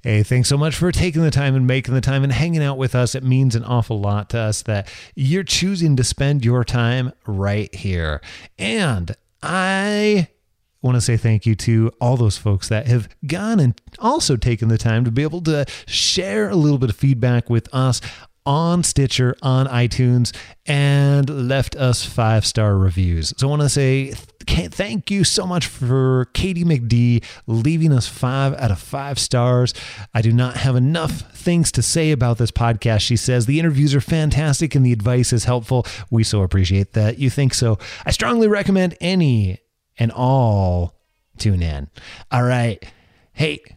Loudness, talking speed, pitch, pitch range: -18 LUFS, 180 wpm, 125 Hz, 110-140 Hz